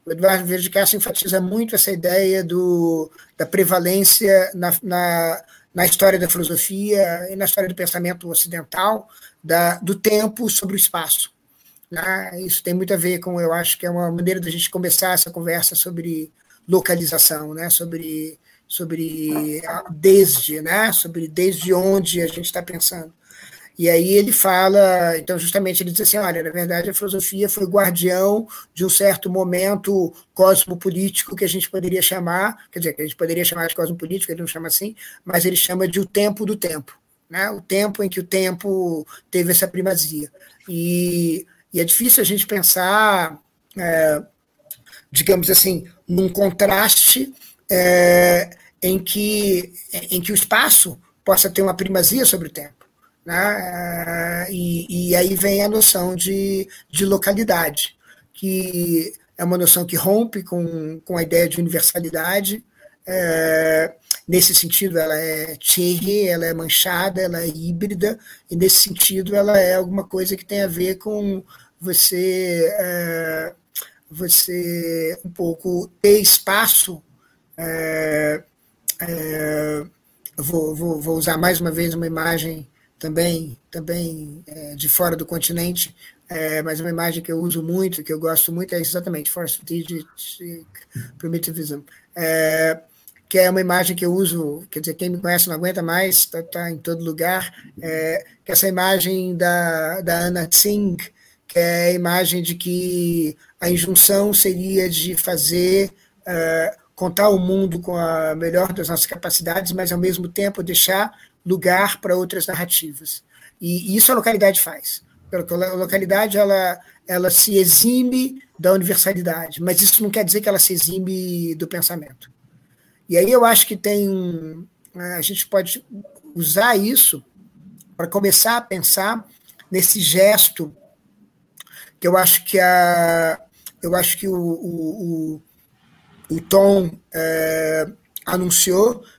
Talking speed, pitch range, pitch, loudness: 150 wpm, 165-195 Hz, 180 Hz, -17 LUFS